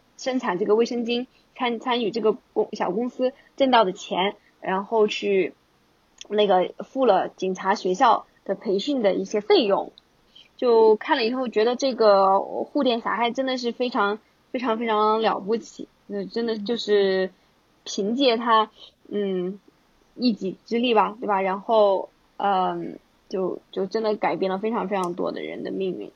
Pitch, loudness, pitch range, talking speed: 215 Hz, -23 LUFS, 195-240 Hz, 230 characters per minute